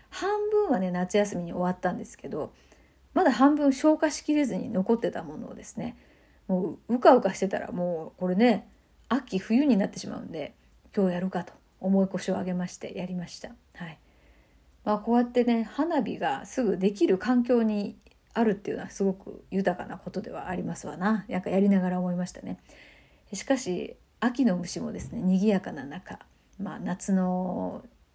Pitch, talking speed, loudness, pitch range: 200 Hz, 355 characters per minute, -27 LUFS, 185-245 Hz